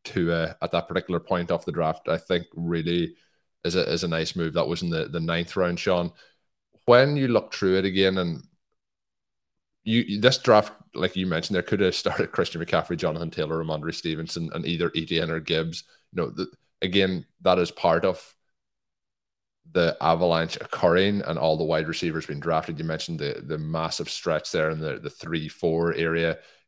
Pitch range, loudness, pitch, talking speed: 80-95 Hz, -25 LUFS, 85 Hz, 190 wpm